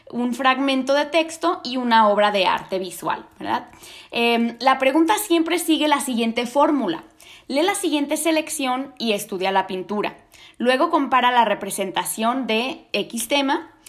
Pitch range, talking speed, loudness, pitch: 230-310 Hz, 145 wpm, -21 LUFS, 260 Hz